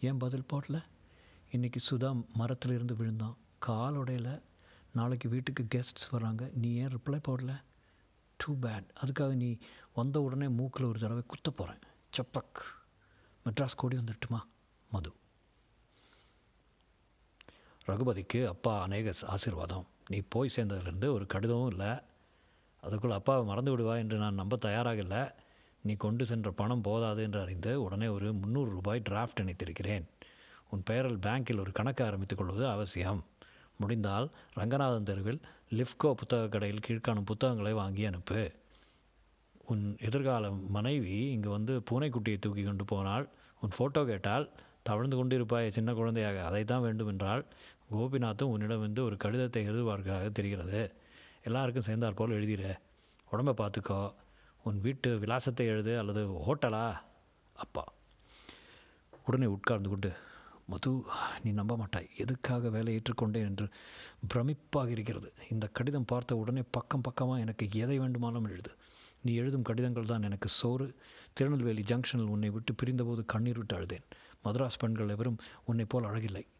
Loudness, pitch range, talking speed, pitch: -35 LUFS, 105-125 Hz, 130 wpm, 115 Hz